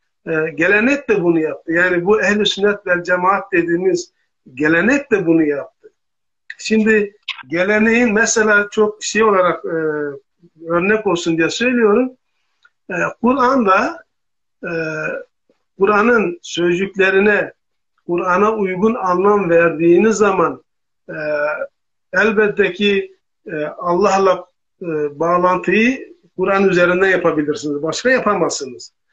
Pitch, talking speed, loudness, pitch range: 195 Hz, 100 wpm, -16 LUFS, 175-220 Hz